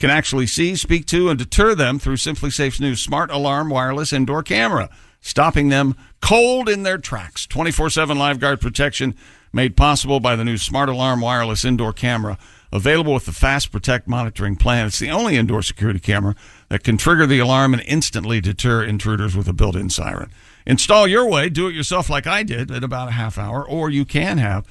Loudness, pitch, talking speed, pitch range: -18 LUFS, 130 Hz, 200 wpm, 115-150 Hz